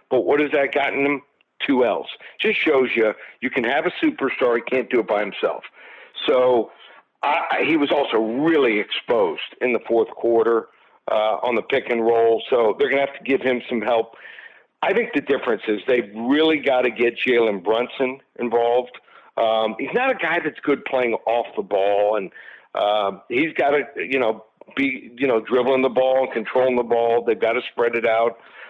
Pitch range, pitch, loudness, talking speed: 115-155 Hz, 130 Hz, -20 LUFS, 200 wpm